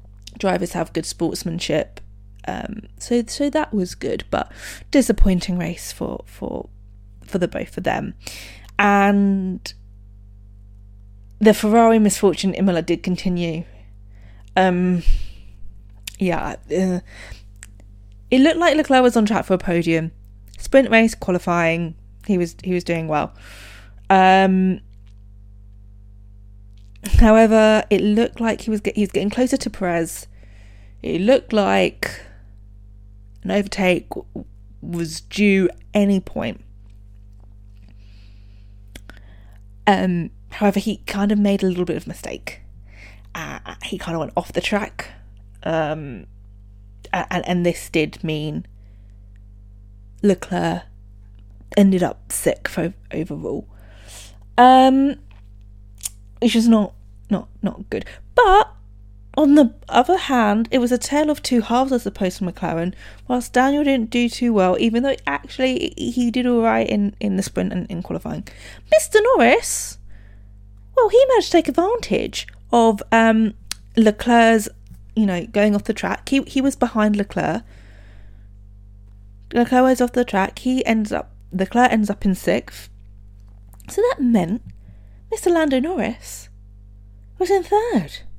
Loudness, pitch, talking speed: -19 LUFS, 170 Hz, 130 wpm